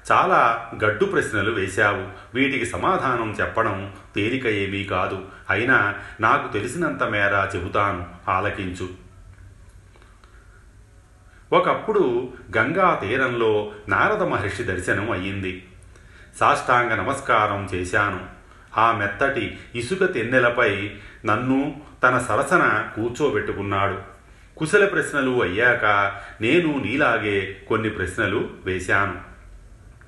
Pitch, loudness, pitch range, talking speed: 100 Hz, -21 LUFS, 95-110 Hz, 85 wpm